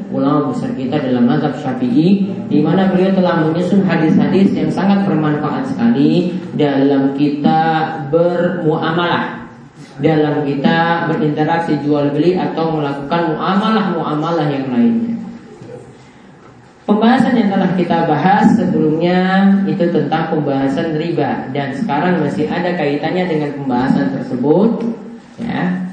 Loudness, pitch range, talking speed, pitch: -15 LUFS, 150-195 Hz, 115 wpm, 165 Hz